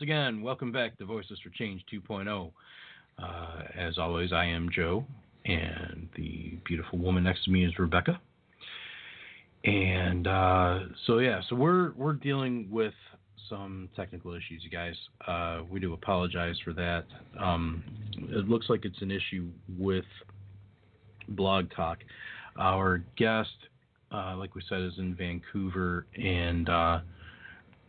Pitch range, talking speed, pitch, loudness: 85-105 Hz, 140 wpm, 95 Hz, -31 LUFS